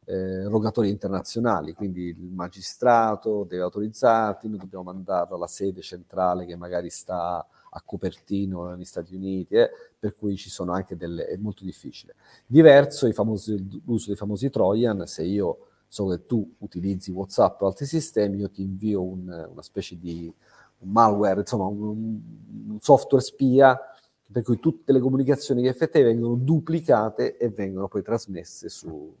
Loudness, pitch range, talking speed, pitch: -24 LUFS, 95-120 Hz, 155 wpm, 105 Hz